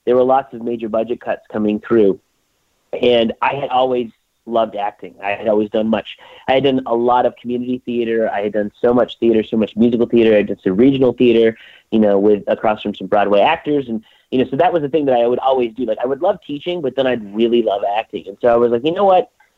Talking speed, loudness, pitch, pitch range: 255 wpm, -16 LUFS, 120 Hz, 110-130 Hz